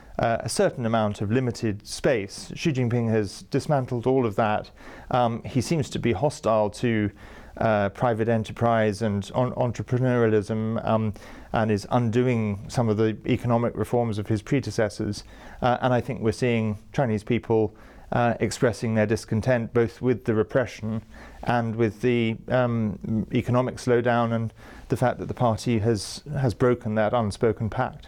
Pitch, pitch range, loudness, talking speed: 115 Hz, 110-125 Hz, -25 LUFS, 155 wpm